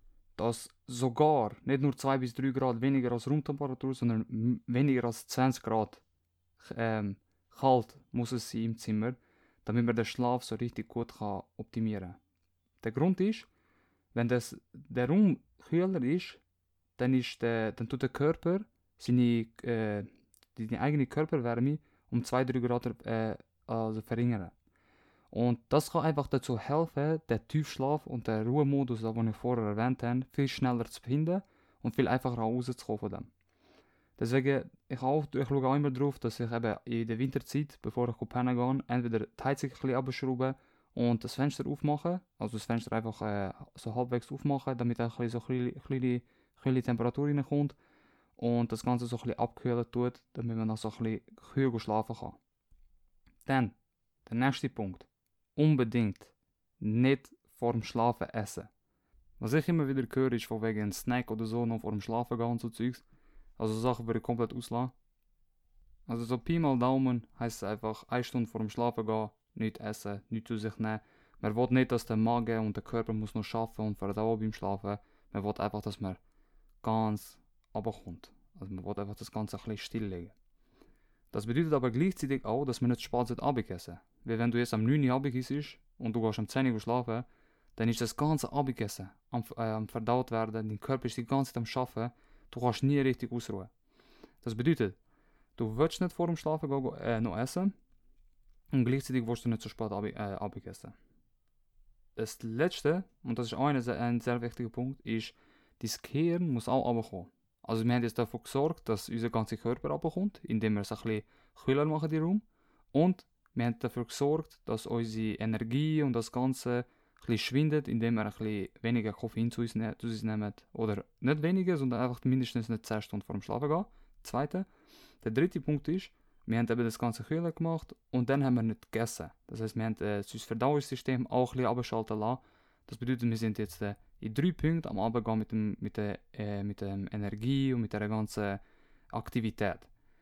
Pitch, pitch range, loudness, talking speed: 120 Hz, 110-130 Hz, -33 LUFS, 180 wpm